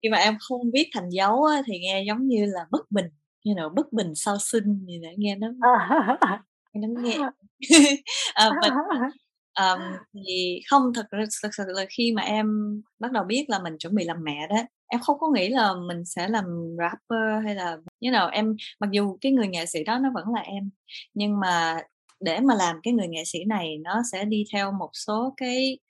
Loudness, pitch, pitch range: -24 LUFS, 215 Hz, 190-240 Hz